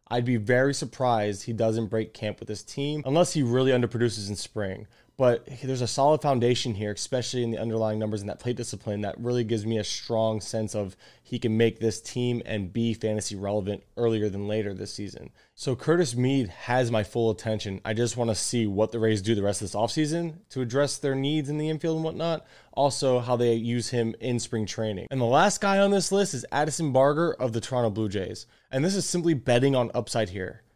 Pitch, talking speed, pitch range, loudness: 120 Hz, 225 wpm, 110-135 Hz, -27 LUFS